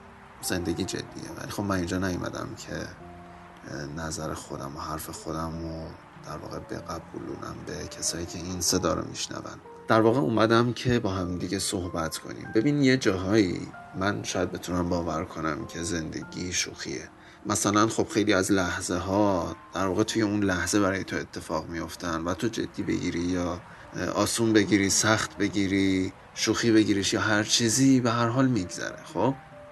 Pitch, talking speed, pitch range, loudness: 95 Hz, 155 wpm, 85-110 Hz, -27 LUFS